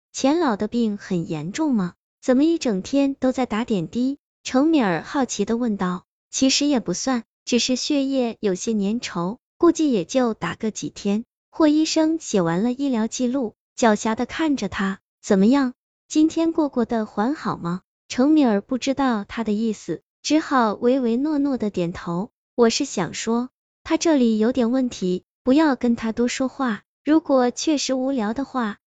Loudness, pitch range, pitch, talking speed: -22 LUFS, 210-275 Hz, 245 Hz, 245 characters per minute